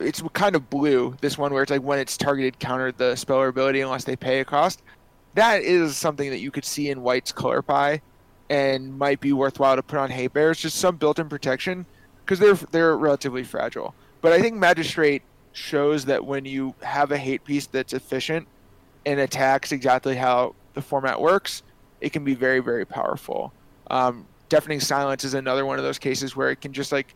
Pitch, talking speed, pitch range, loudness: 135 Hz, 205 wpm, 130-145 Hz, -23 LUFS